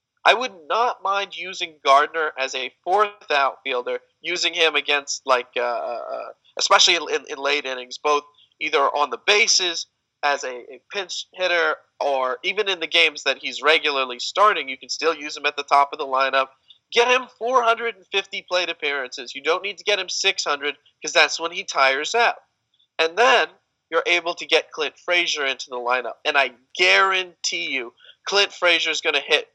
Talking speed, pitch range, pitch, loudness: 180 wpm, 140-200 Hz, 165 Hz, -20 LUFS